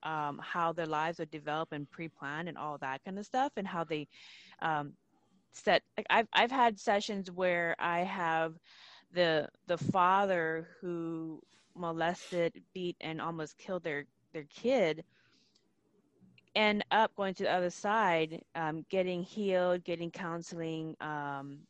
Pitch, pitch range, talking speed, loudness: 170 Hz, 160-185 Hz, 140 wpm, -34 LUFS